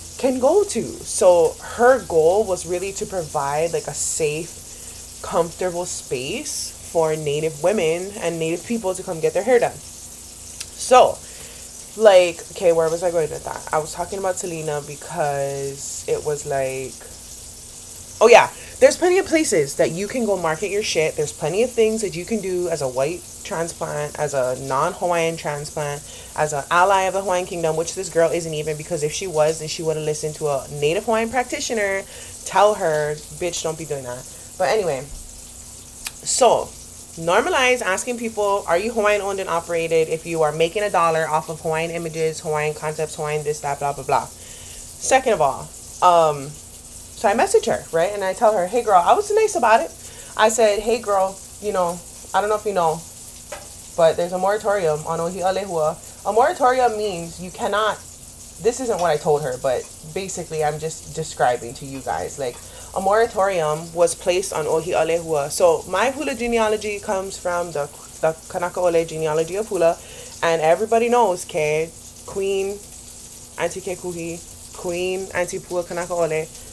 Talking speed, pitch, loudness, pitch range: 180 wpm, 175 Hz, -21 LUFS, 155-205 Hz